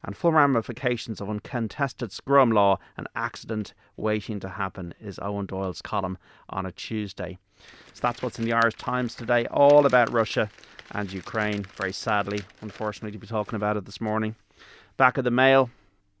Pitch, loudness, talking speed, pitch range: 110 Hz, -25 LUFS, 170 wpm, 100-120 Hz